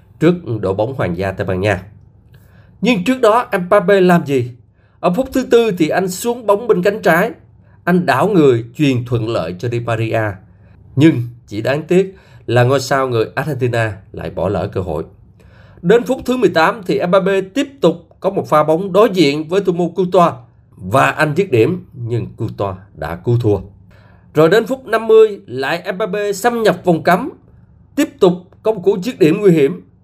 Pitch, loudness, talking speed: 155 Hz, -15 LUFS, 185 wpm